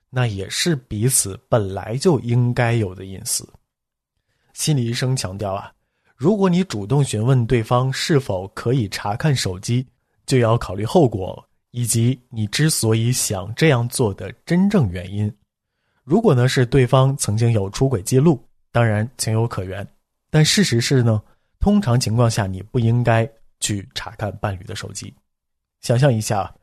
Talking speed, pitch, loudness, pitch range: 235 characters per minute, 120 Hz, -19 LUFS, 105-130 Hz